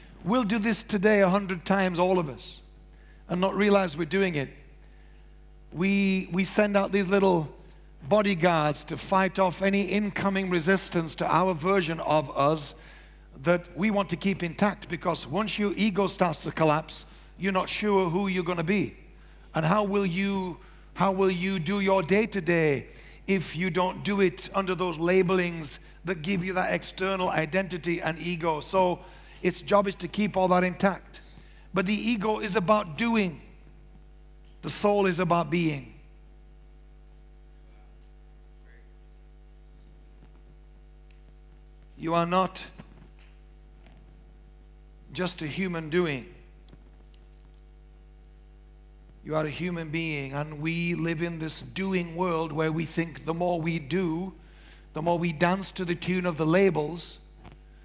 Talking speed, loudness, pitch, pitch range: 145 wpm, -27 LUFS, 180 Hz, 160-195 Hz